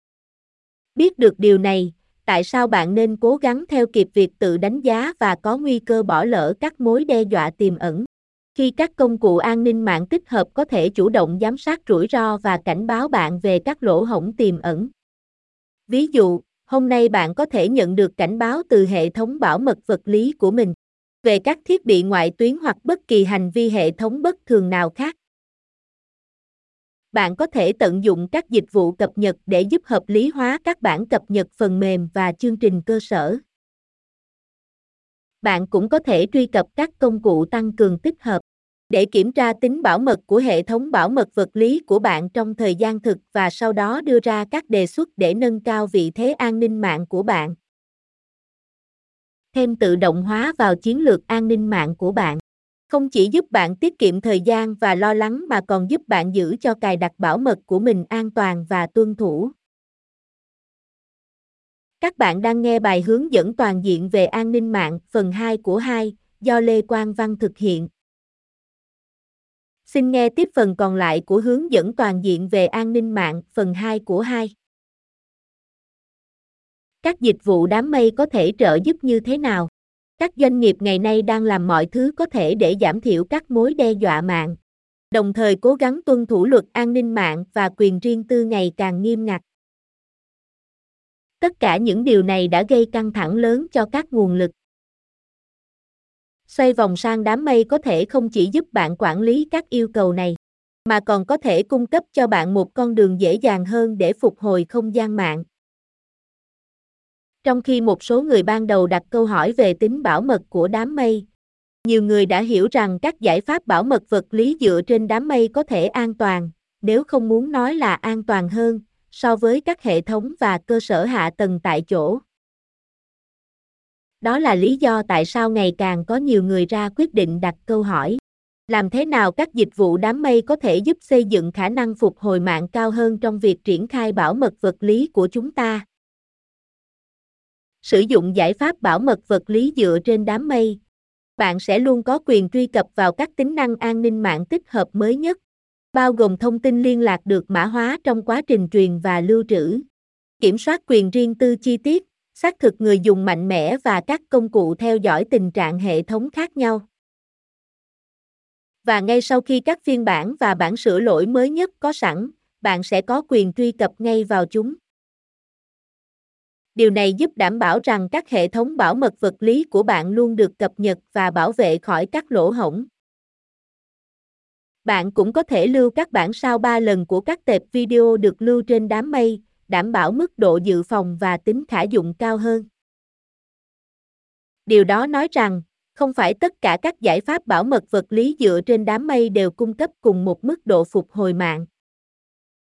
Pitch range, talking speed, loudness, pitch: 195-250 Hz, 200 wpm, -18 LUFS, 220 Hz